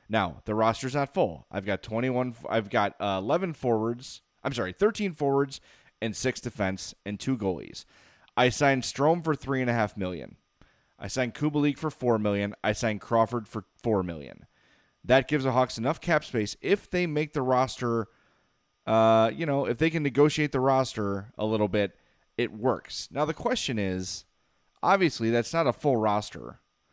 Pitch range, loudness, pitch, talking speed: 105-140 Hz, -27 LUFS, 120 Hz, 180 wpm